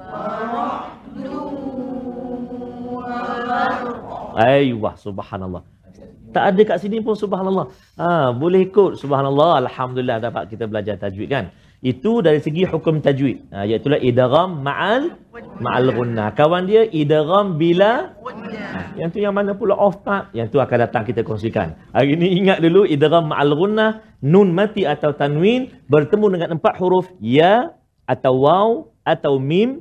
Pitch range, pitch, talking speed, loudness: 130-210 Hz, 170 Hz, 130 wpm, -18 LUFS